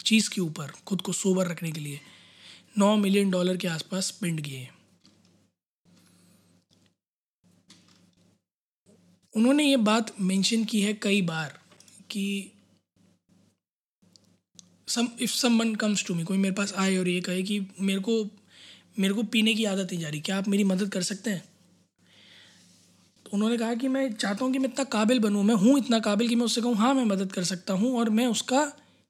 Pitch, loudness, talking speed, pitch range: 200 Hz, -26 LUFS, 170 wpm, 185-230 Hz